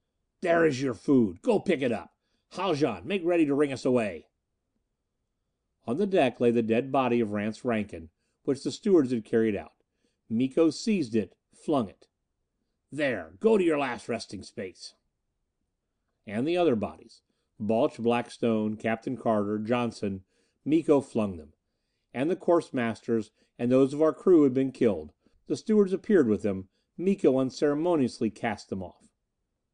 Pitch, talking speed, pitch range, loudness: 125 Hz, 155 wpm, 110-155 Hz, -27 LUFS